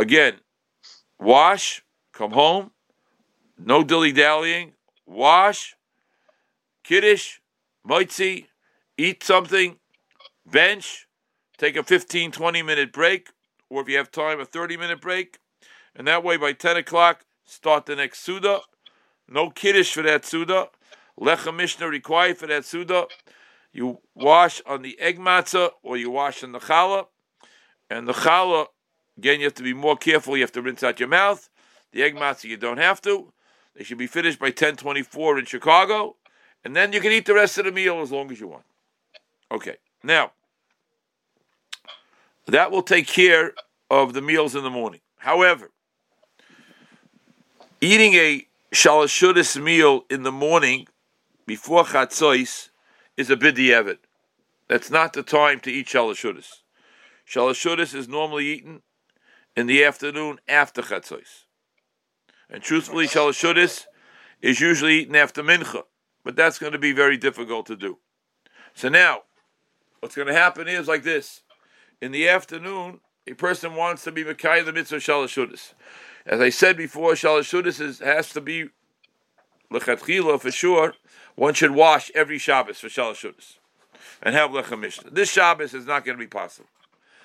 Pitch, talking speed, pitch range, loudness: 160 Hz, 150 wpm, 140-180 Hz, -20 LUFS